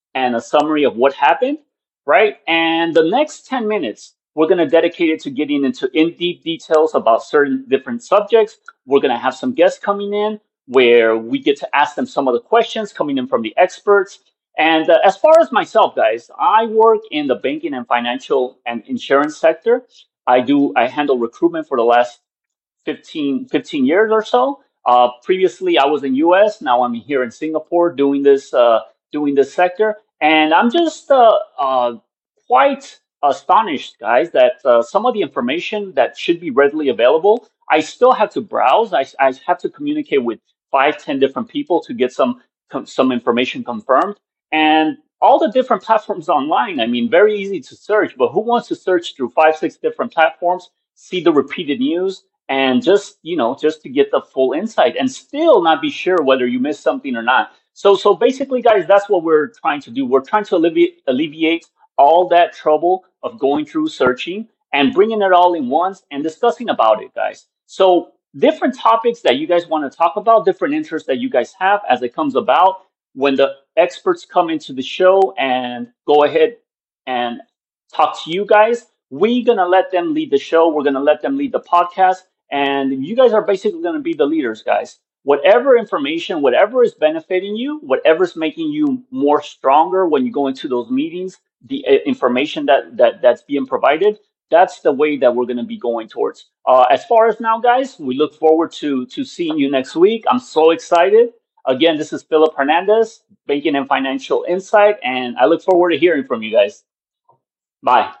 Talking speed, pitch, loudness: 190 wpm, 185 Hz, -15 LUFS